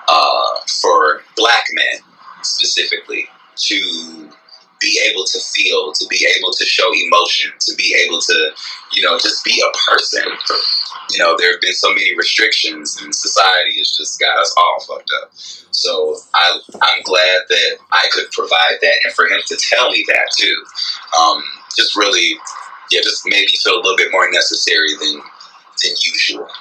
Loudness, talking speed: -13 LUFS, 170 wpm